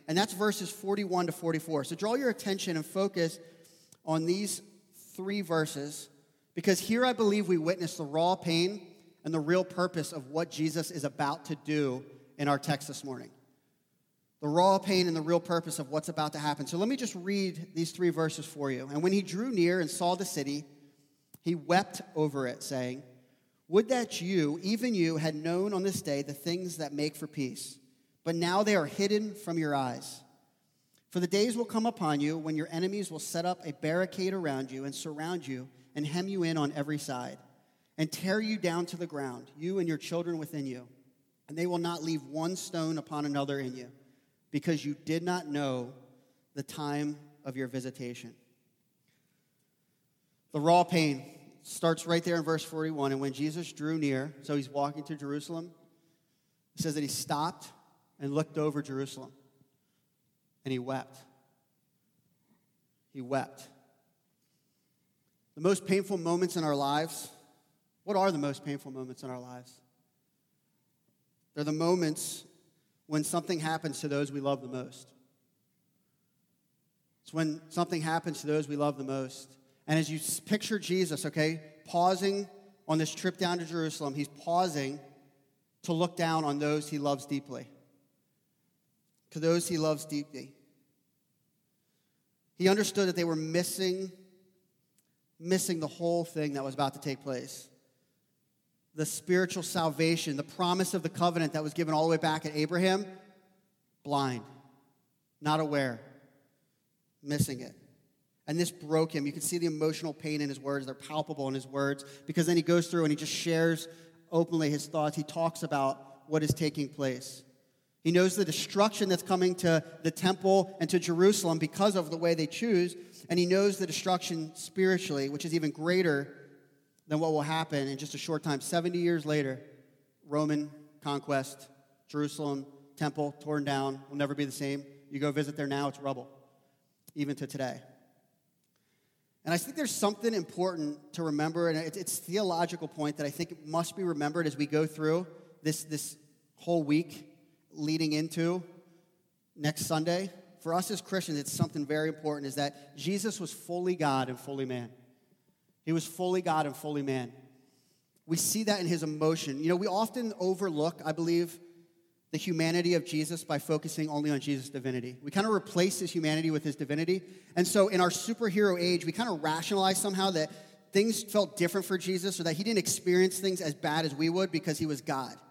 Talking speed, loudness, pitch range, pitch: 175 wpm, -32 LUFS, 145-175 Hz, 160 Hz